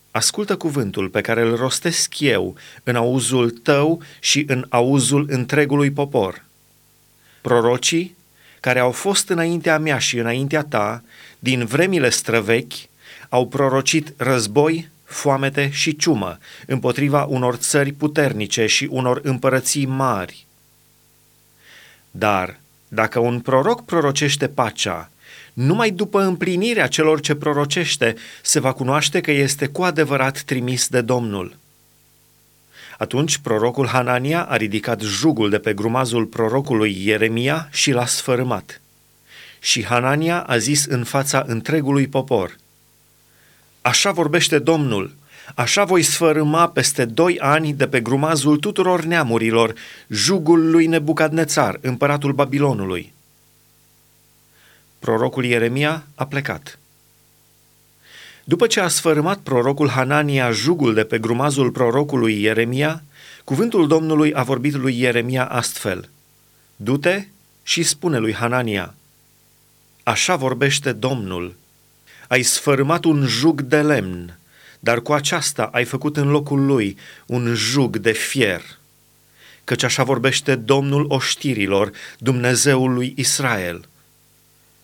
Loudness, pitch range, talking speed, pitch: -18 LUFS, 120-150 Hz, 115 wpm, 135 Hz